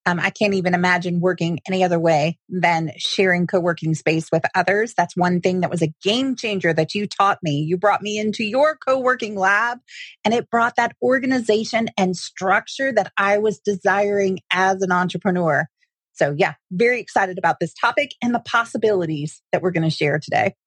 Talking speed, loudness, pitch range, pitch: 185 wpm, -20 LUFS, 175-220 Hz, 190 Hz